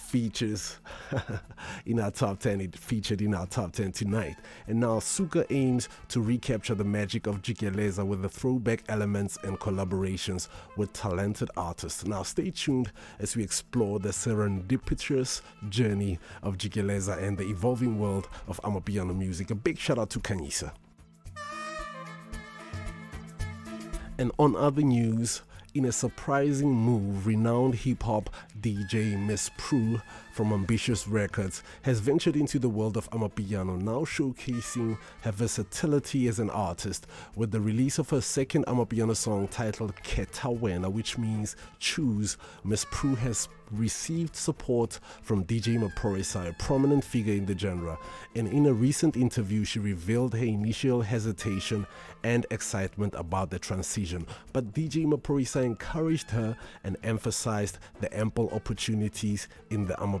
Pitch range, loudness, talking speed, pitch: 100-125 Hz, -30 LUFS, 140 wpm, 110 Hz